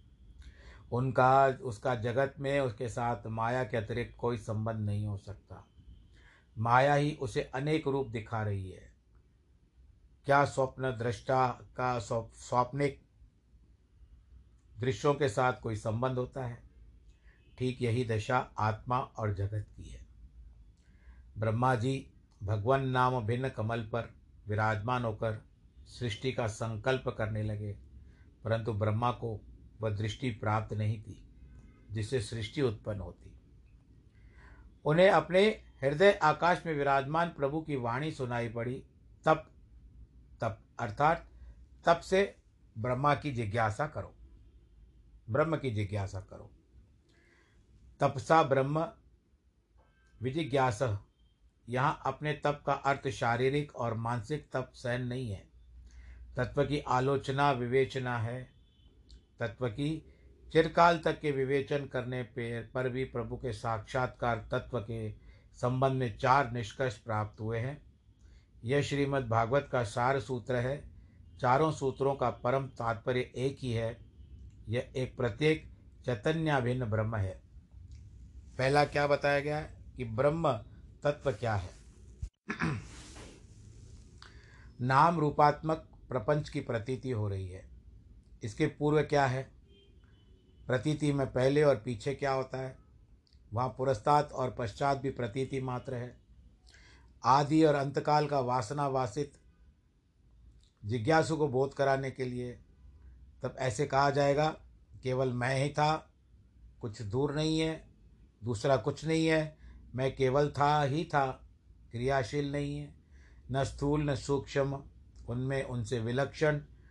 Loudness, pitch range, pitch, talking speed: -32 LUFS, 105-135 Hz, 125 Hz, 120 wpm